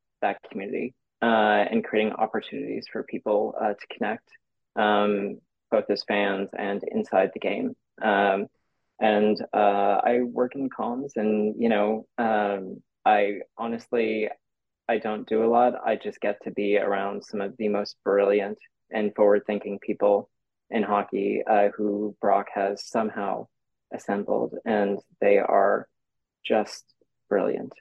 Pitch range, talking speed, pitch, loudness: 100-110 Hz, 140 wpm, 105 Hz, -25 LUFS